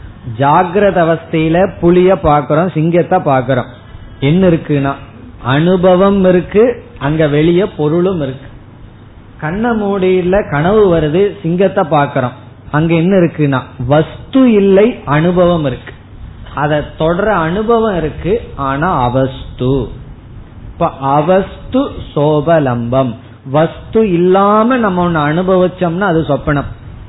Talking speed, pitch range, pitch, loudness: 95 wpm, 130-185 Hz, 155 Hz, -12 LUFS